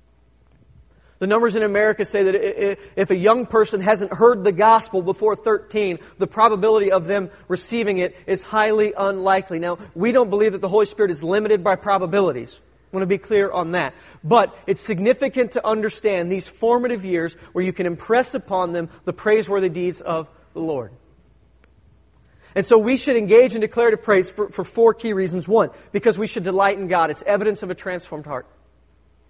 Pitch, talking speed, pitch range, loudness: 200 Hz, 185 wpm, 180-220 Hz, -19 LUFS